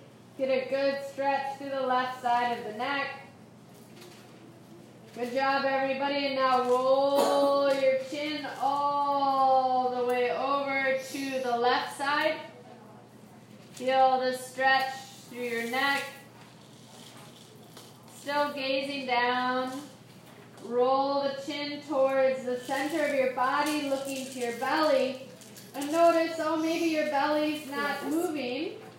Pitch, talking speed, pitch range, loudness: 270 Hz, 120 wpm, 260-280 Hz, -28 LUFS